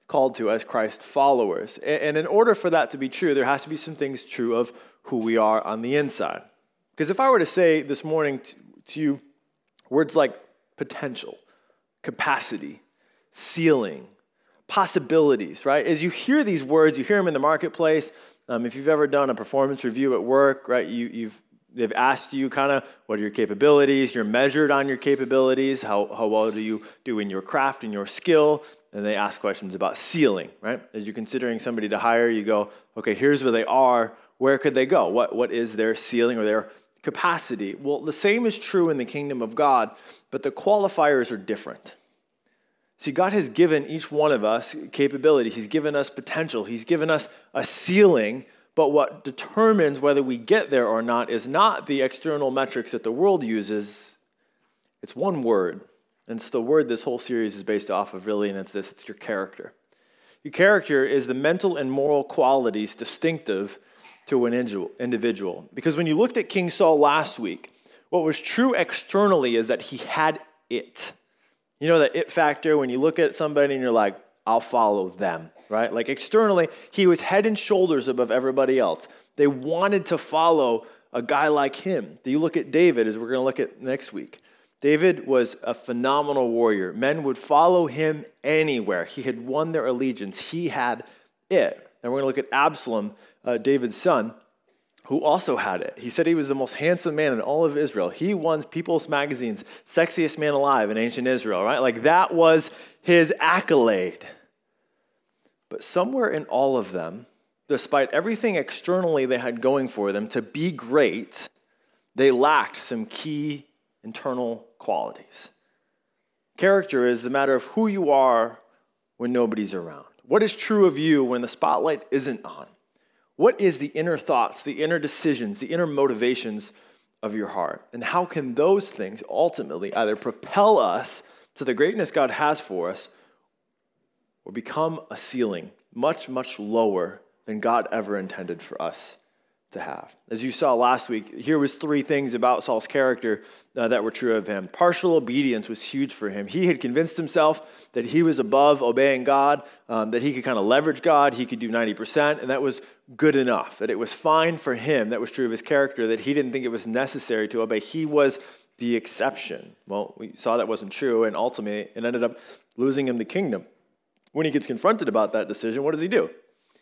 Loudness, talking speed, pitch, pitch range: -23 LUFS, 190 wpm, 140 Hz, 120-160 Hz